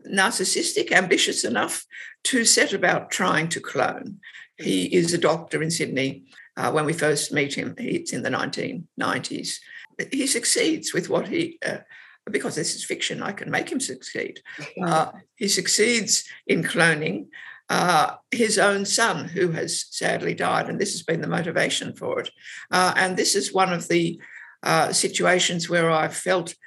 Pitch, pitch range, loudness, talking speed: 185 Hz, 170-230 Hz, -23 LUFS, 165 wpm